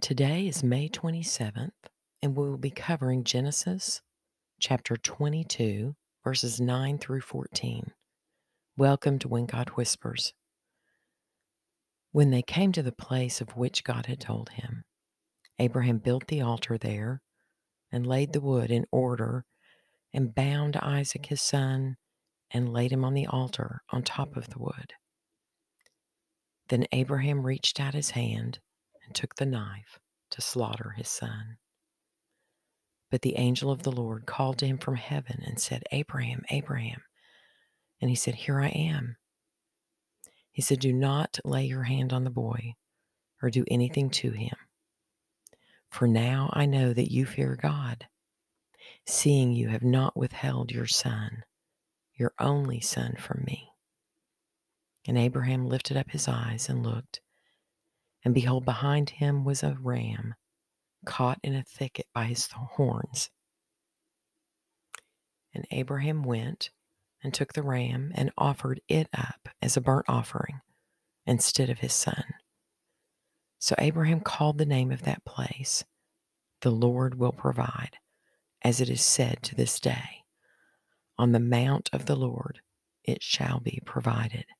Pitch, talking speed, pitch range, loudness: 130 Hz, 140 wpm, 120-140 Hz, -29 LUFS